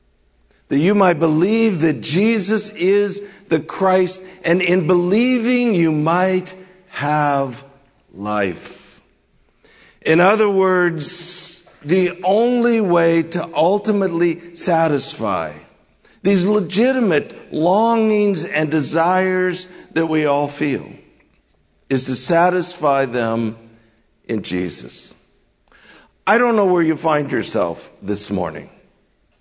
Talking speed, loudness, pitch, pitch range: 100 wpm, -17 LUFS, 175 Hz, 145-190 Hz